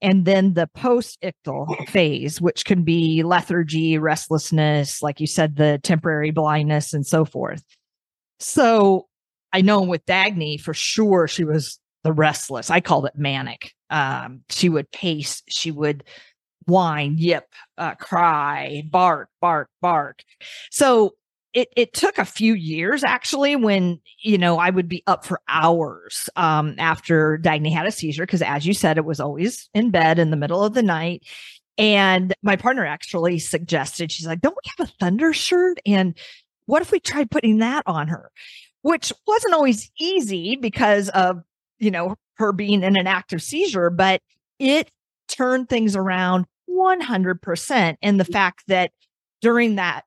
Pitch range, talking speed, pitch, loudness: 160-215 Hz, 160 wpm, 180 Hz, -20 LUFS